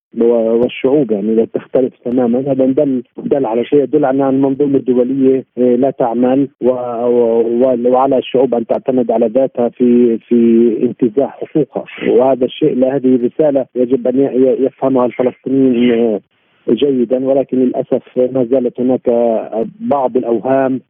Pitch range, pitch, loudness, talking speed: 120-135 Hz, 125 Hz, -13 LUFS, 120 wpm